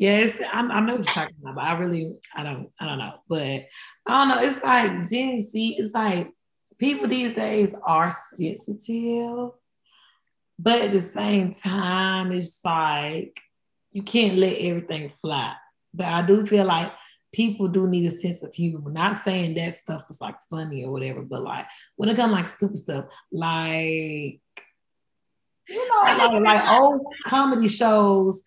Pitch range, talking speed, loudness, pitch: 165-225 Hz, 160 wpm, -23 LUFS, 195 Hz